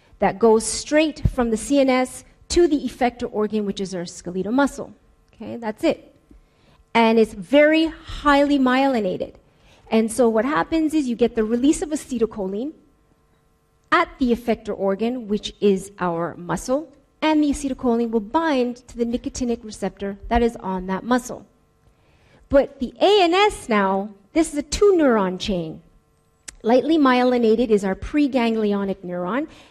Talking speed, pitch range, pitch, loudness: 145 wpm, 210-280 Hz, 235 Hz, -21 LUFS